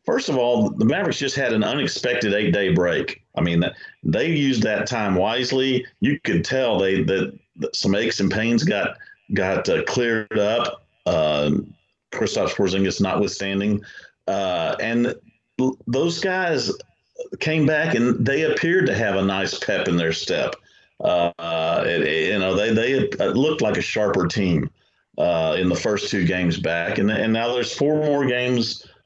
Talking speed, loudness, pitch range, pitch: 170 wpm, -21 LUFS, 95-140 Hz, 115 Hz